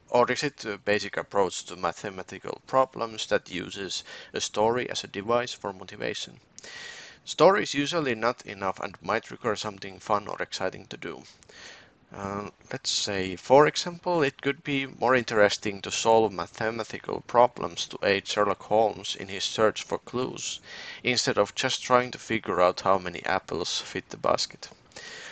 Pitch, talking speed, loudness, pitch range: 110 Hz, 160 wpm, -27 LUFS, 100-125 Hz